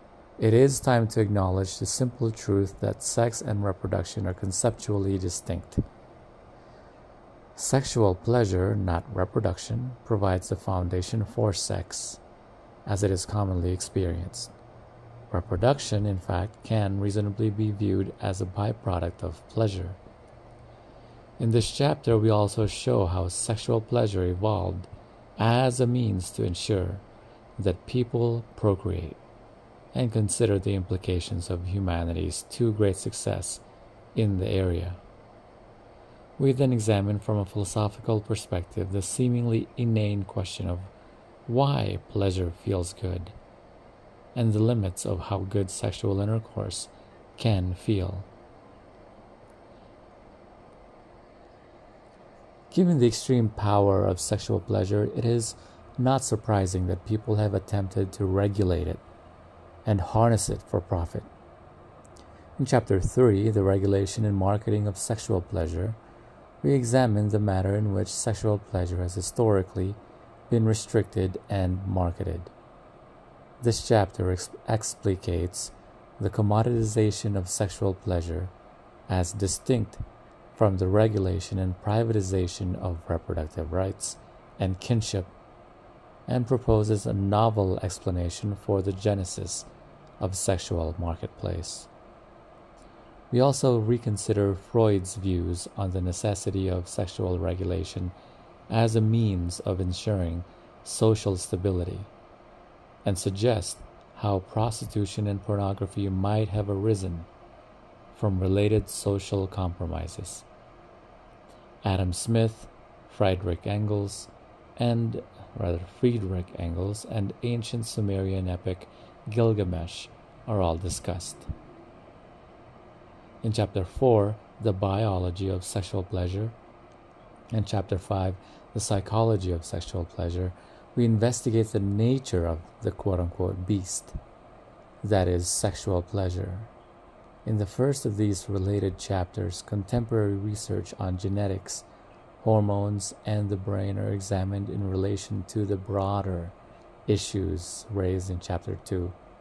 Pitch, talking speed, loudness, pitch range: 100 Hz, 110 wpm, -27 LUFS, 95-110 Hz